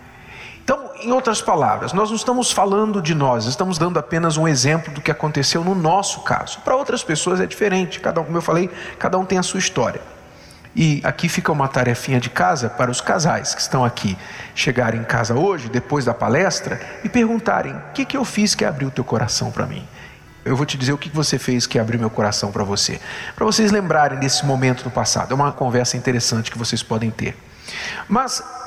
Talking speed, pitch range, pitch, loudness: 210 wpm, 125-185 Hz, 150 Hz, -19 LUFS